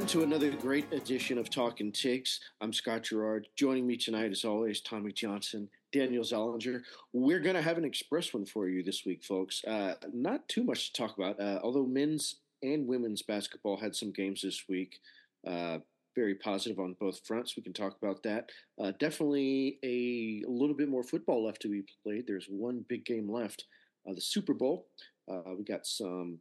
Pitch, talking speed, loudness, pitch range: 110 Hz, 195 wpm, -35 LUFS, 100-130 Hz